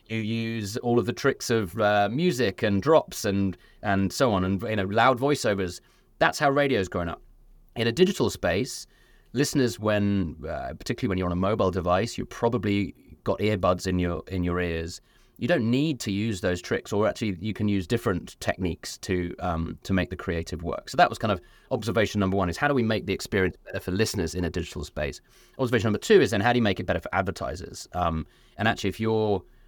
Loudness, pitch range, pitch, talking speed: -26 LUFS, 90-115 Hz, 100 Hz, 220 wpm